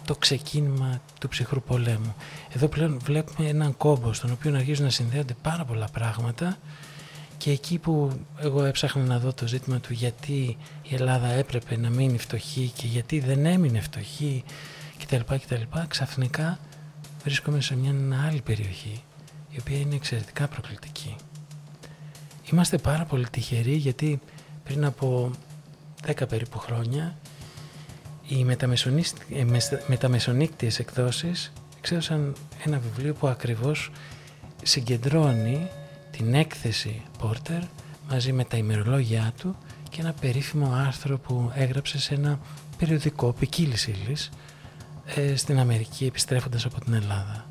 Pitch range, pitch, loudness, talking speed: 125-150 Hz, 140 Hz, -27 LUFS, 125 wpm